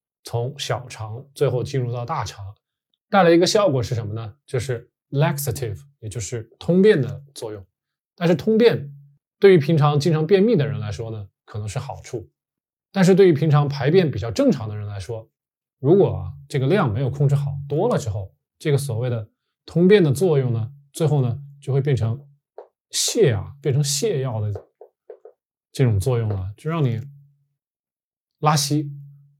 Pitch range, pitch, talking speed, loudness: 115-150 Hz, 140 Hz, 255 characters per minute, -20 LUFS